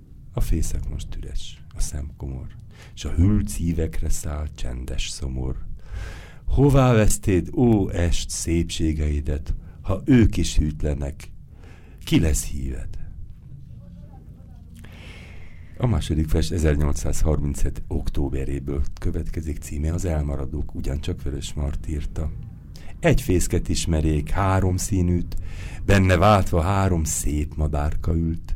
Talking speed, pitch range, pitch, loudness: 105 wpm, 75-90 Hz, 80 Hz, -24 LUFS